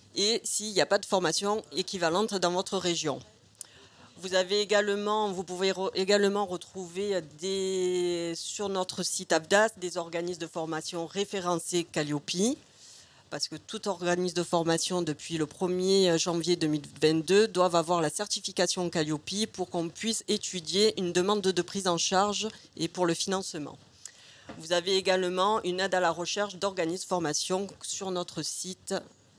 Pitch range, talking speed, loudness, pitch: 170-195 Hz, 150 wpm, -29 LUFS, 180 Hz